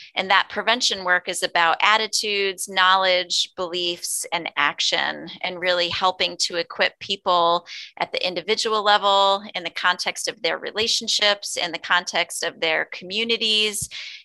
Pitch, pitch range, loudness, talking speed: 185 Hz, 175-210 Hz, -21 LUFS, 140 wpm